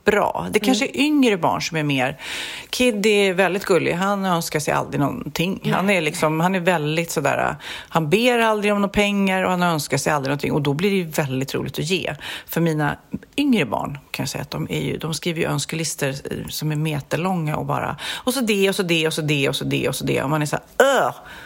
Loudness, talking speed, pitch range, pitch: -21 LUFS, 250 wpm, 150-200 Hz, 170 Hz